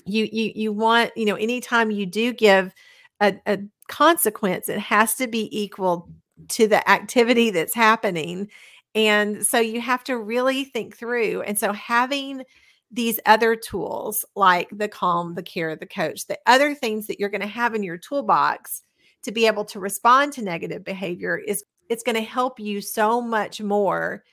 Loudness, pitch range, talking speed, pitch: -21 LUFS, 200-235 Hz, 180 wpm, 215 Hz